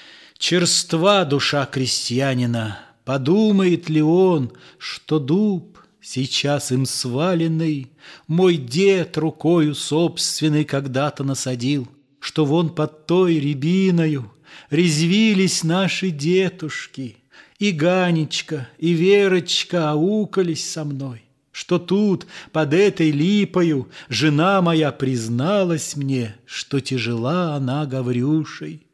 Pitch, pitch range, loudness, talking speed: 155 Hz, 140-180 Hz, -19 LUFS, 95 wpm